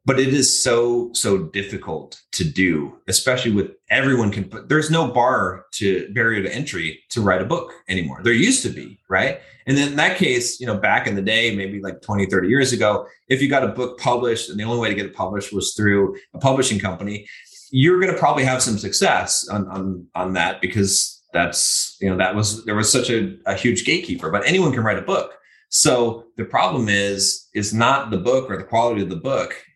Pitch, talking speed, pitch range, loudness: 110 Hz, 220 wpm, 100-130 Hz, -19 LUFS